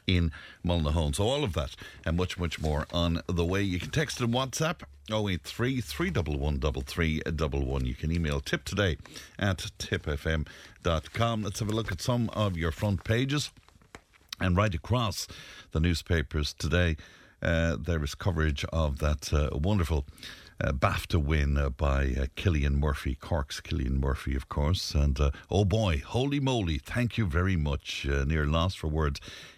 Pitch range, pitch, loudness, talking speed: 75-100 Hz, 85 Hz, -30 LUFS, 160 wpm